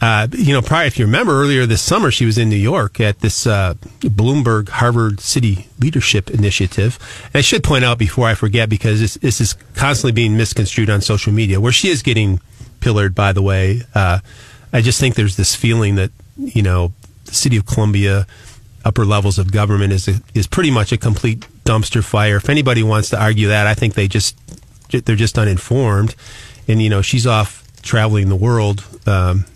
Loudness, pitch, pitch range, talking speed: -15 LUFS, 110 Hz, 105-120 Hz, 200 wpm